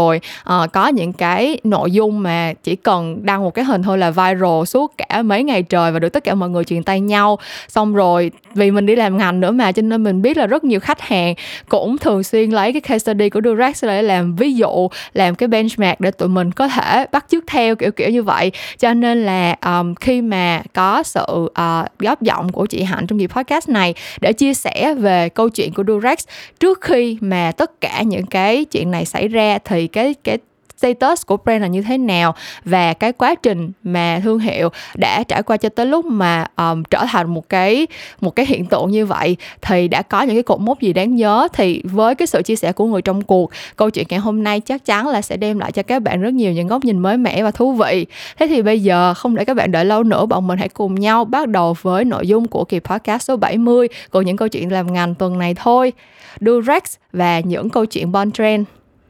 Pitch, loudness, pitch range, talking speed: 205 Hz, -16 LUFS, 180-235 Hz, 240 wpm